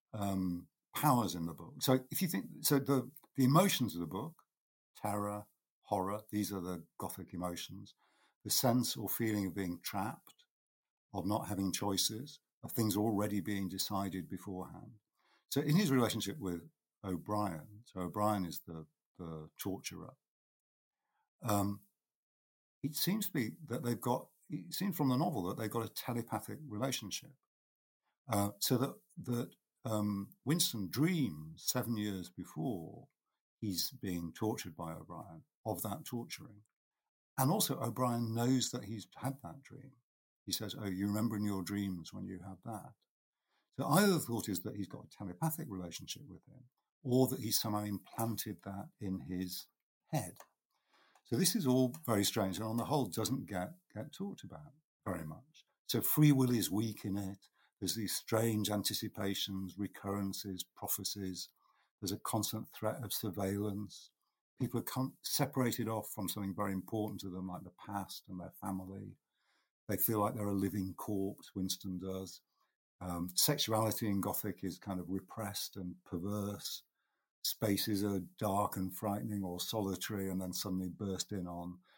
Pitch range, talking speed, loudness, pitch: 95-125 Hz, 160 wpm, -37 LUFS, 105 Hz